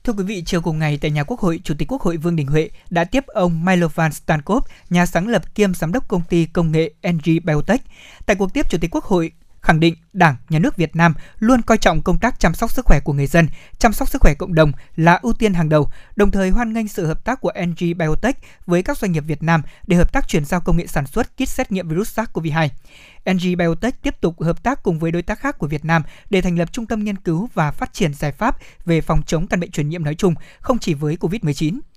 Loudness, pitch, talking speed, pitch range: -19 LUFS, 175 Hz, 265 wpm, 160-210 Hz